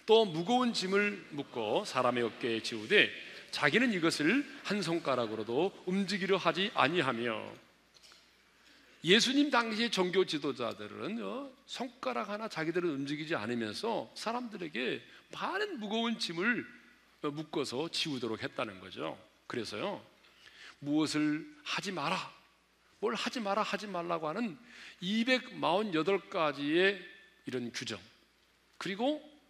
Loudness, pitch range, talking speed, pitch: -33 LUFS, 150-230 Hz, 260 characters per minute, 190 Hz